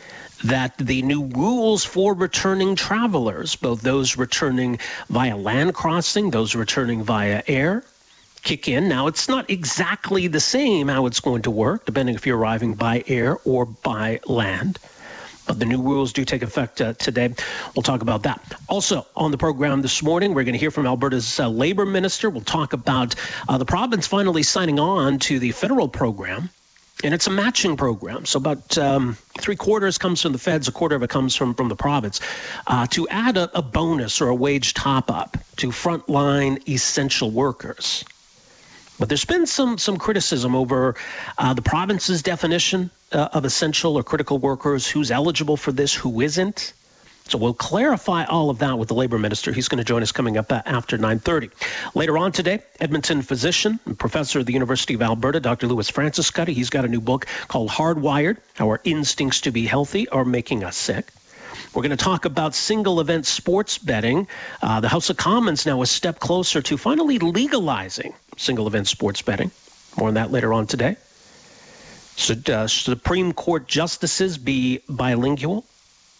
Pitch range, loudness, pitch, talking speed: 125-175 Hz, -21 LUFS, 140 Hz, 180 wpm